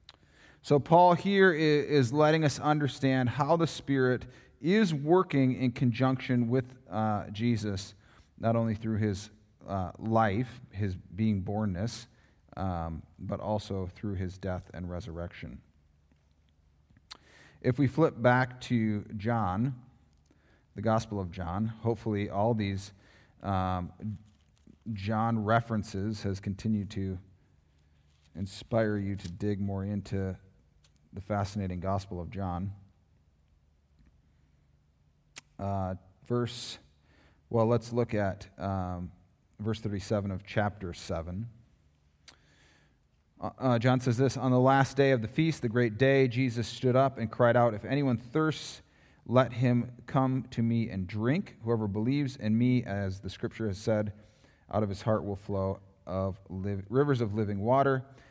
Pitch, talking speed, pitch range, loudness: 105 Hz, 130 wpm, 95-125 Hz, -30 LUFS